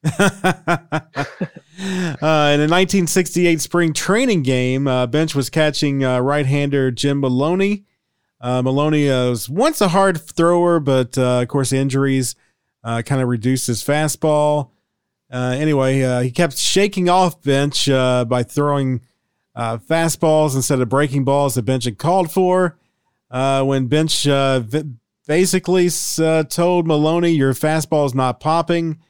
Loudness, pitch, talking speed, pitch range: -17 LUFS, 145 Hz, 140 wpm, 130-170 Hz